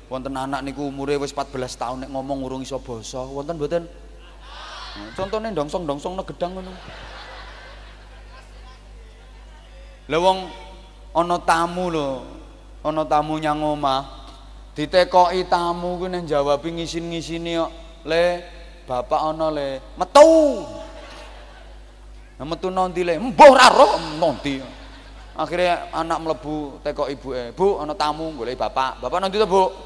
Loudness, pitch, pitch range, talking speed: -20 LUFS, 155 Hz, 140-180 Hz, 125 wpm